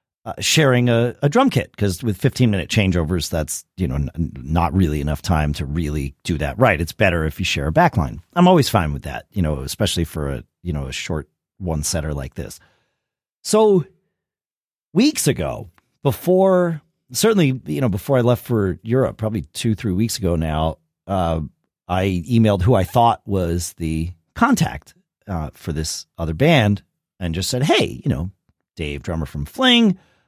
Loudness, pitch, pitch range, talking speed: -19 LUFS, 95 Hz, 80-120 Hz, 180 wpm